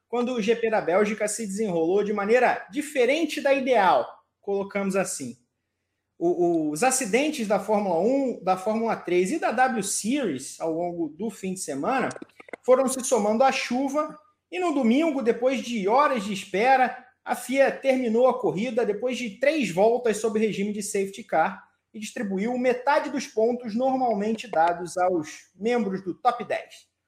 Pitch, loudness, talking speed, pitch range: 235 Hz, -24 LUFS, 160 wpm, 200-260 Hz